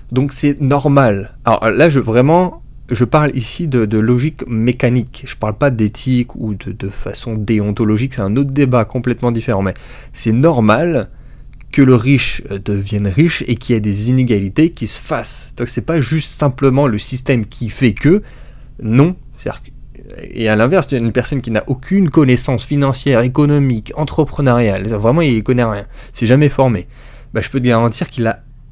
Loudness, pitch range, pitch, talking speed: -14 LUFS, 115-140 Hz, 125 Hz, 180 wpm